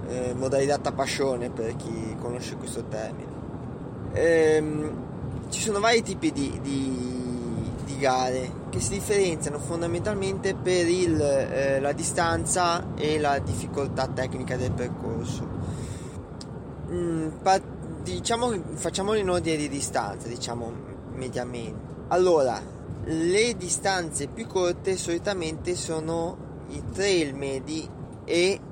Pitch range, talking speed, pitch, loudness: 130-175 Hz, 115 wpm, 145 Hz, -27 LUFS